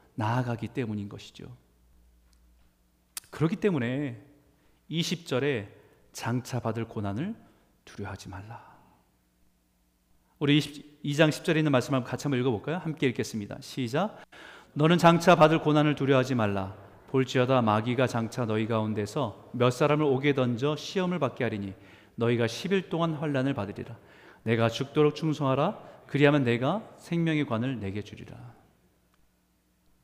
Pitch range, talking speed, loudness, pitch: 105-145 Hz, 290 characters per minute, -27 LUFS, 125 Hz